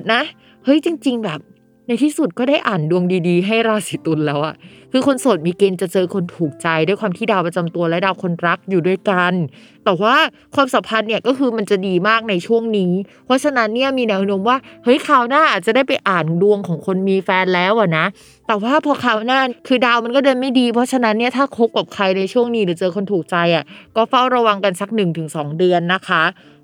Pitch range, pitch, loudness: 180-245 Hz, 205 Hz, -17 LUFS